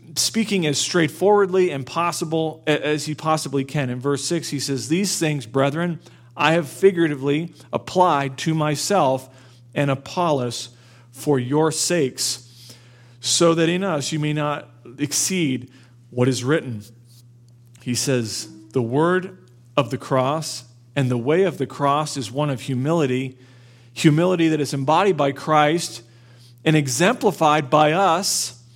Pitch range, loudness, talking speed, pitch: 125-160 Hz, -21 LUFS, 140 wpm, 140 Hz